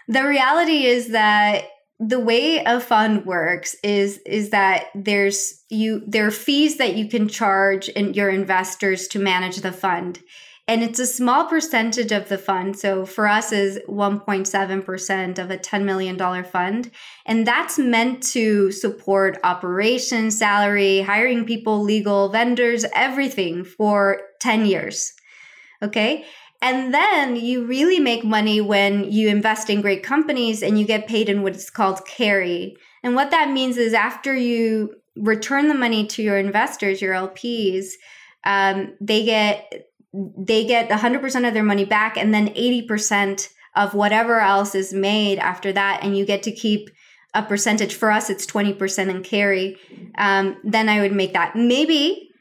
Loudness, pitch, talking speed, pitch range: -19 LUFS, 210 Hz, 155 wpm, 195-235 Hz